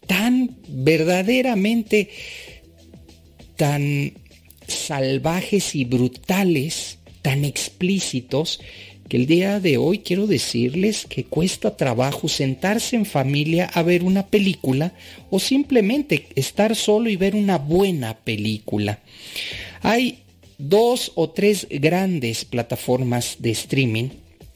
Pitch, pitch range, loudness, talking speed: 155 Hz, 120-195 Hz, -21 LUFS, 105 wpm